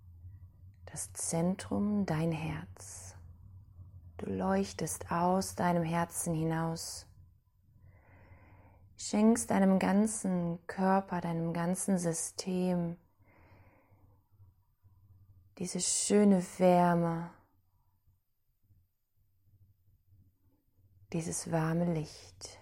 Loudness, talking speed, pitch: -32 LUFS, 60 wpm, 100 Hz